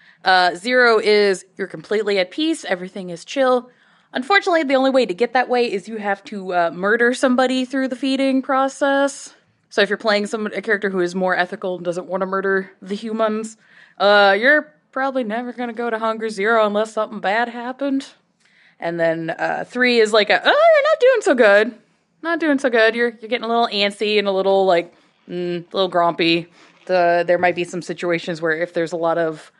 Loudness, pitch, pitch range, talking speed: -18 LUFS, 210 Hz, 185-250 Hz, 210 wpm